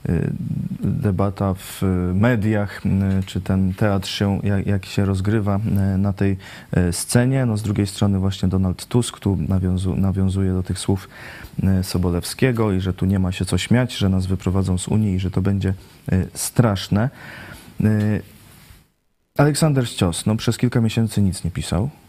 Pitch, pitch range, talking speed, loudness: 100 Hz, 95-105 Hz, 150 wpm, -21 LUFS